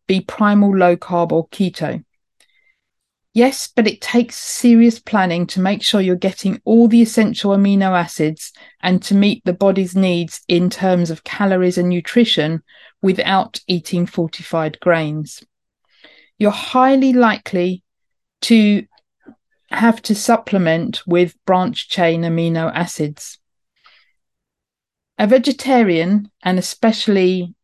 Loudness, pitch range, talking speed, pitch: -16 LUFS, 175-225 Hz, 115 wpm, 190 Hz